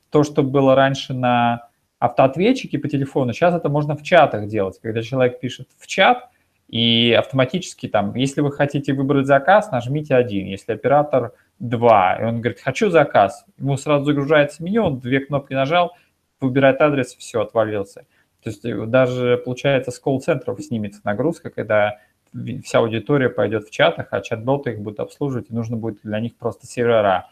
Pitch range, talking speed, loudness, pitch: 120-145 Hz, 165 wpm, -19 LUFS, 135 Hz